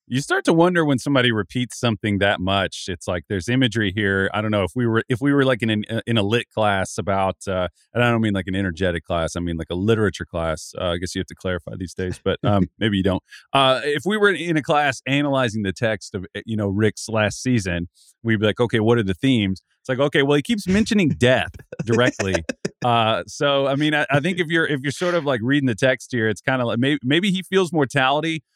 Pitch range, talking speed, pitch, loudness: 95-140 Hz, 255 wpm, 115 Hz, -21 LUFS